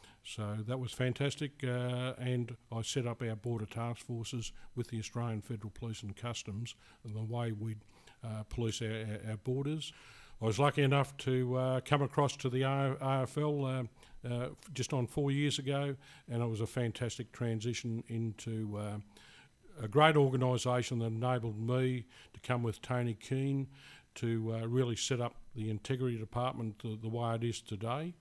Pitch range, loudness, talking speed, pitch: 115-130 Hz, -36 LUFS, 170 wpm, 120 Hz